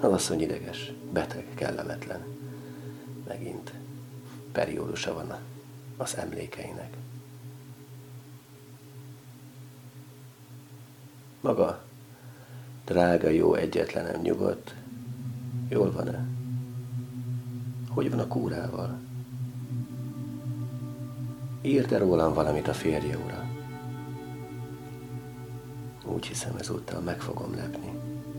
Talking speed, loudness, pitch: 70 wpm, -31 LUFS, 125 Hz